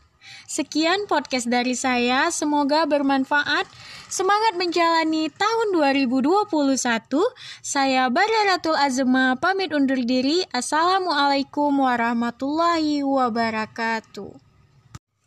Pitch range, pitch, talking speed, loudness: 250-335 Hz, 285 Hz, 75 wpm, -21 LUFS